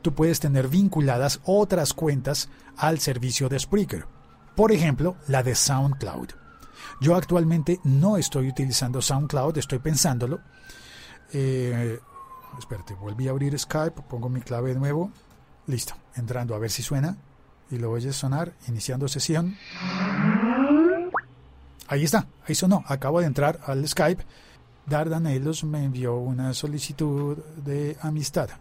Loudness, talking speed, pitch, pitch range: -25 LUFS, 135 wpm, 145 Hz, 130-165 Hz